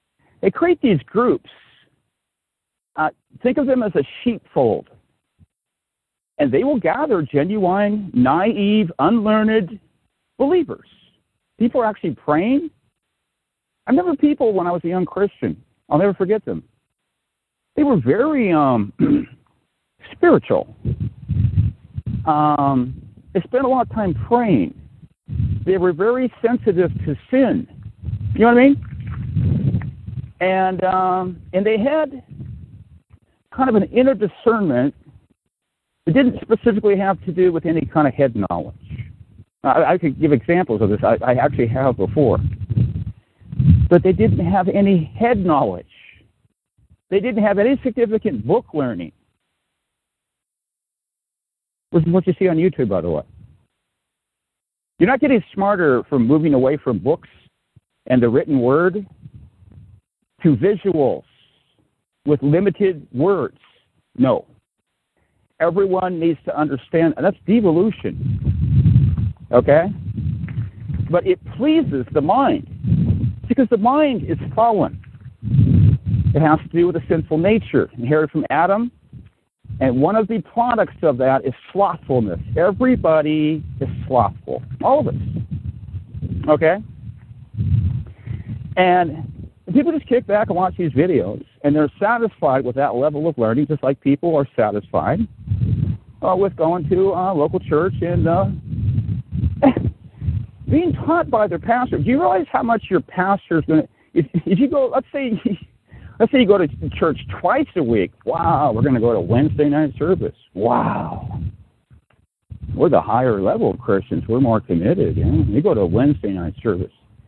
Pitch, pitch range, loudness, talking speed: 165 Hz, 125-210 Hz, -18 LUFS, 135 wpm